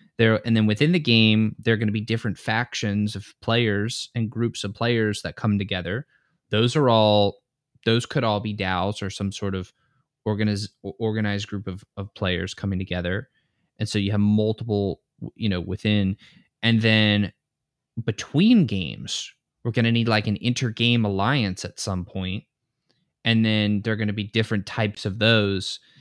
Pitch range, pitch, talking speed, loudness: 100-115 Hz, 110 Hz, 175 wpm, -23 LUFS